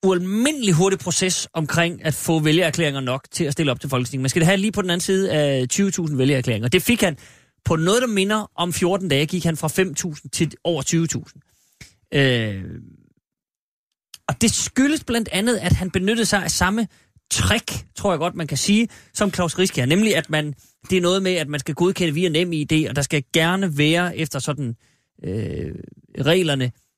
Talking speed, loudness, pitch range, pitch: 200 wpm, -20 LUFS, 140-185 Hz, 165 Hz